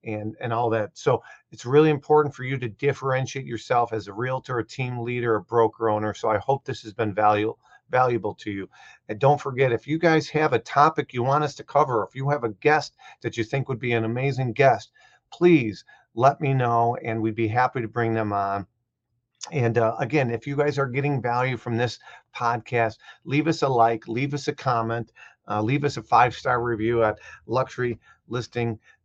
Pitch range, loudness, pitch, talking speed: 115-140 Hz, -24 LUFS, 120 Hz, 210 wpm